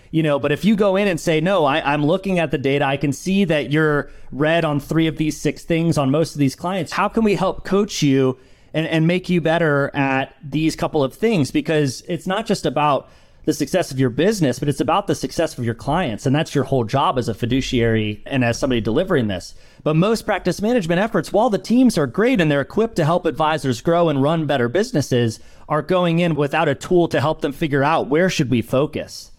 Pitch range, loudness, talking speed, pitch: 140-175 Hz, -19 LUFS, 235 wpm, 155 Hz